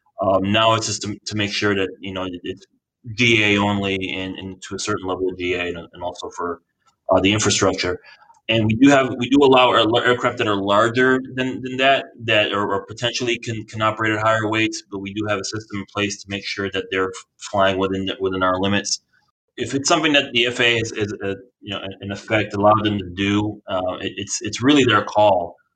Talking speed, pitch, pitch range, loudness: 220 wpm, 105 Hz, 95-115 Hz, -19 LUFS